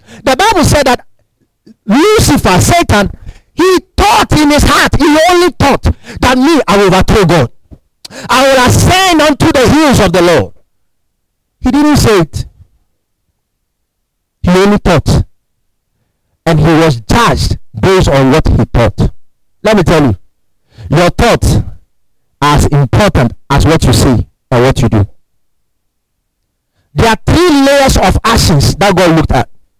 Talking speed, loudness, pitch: 145 wpm, -8 LUFS, 185 Hz